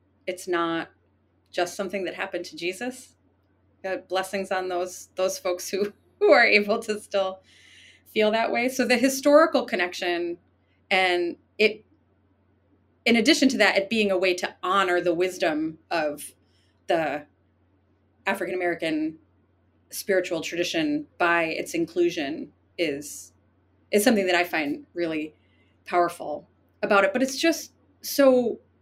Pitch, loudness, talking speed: 175 Hz, -24 LUFS, 130 wpm